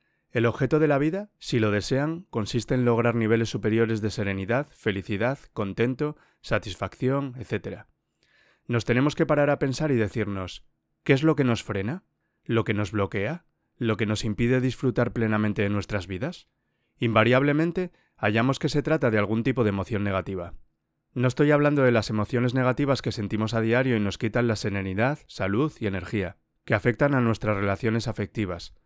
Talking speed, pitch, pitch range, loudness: 170 wpm, 115 Hz, 105-130 Hz, -25 LUFS